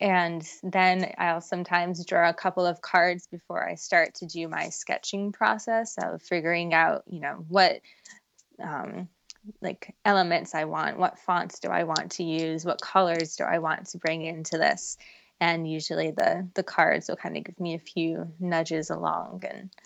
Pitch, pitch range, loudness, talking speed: 175 Hz, 165-185 Hz, -27 LUFS, 180 wpm